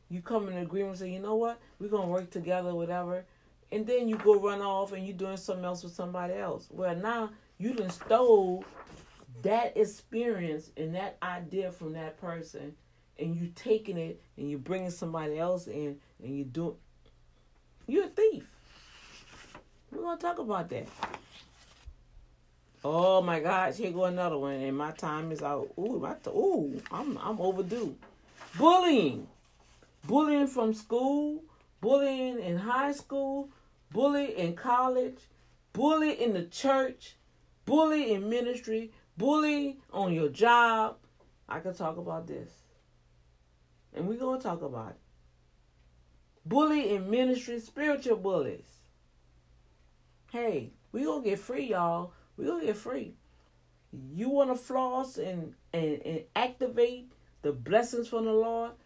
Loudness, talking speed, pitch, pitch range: -31 LUFS, 145 wpm, 190 Hz, 155-235 Hz